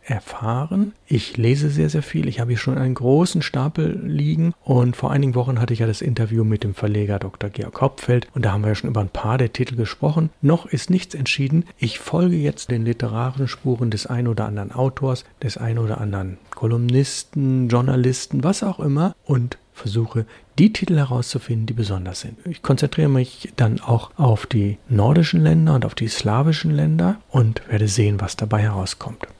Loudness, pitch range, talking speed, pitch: -20 LUFS, 115-150 Hz, 190 wpm, 125 Hz